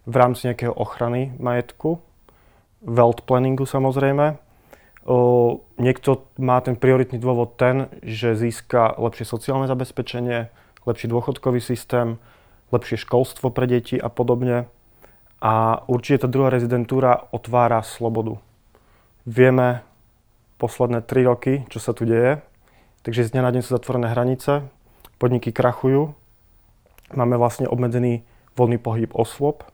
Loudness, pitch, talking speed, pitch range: -21 LUFS, 120 Hz, 120 wpm, 115-130 Hz